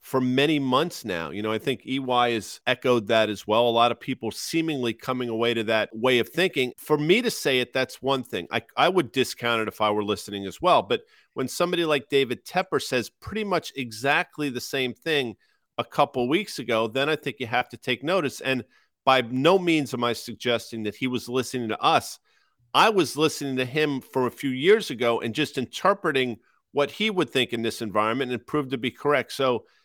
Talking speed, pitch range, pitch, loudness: 220 wpm, 120-150 Hz, 130 Hz, -25 LUFS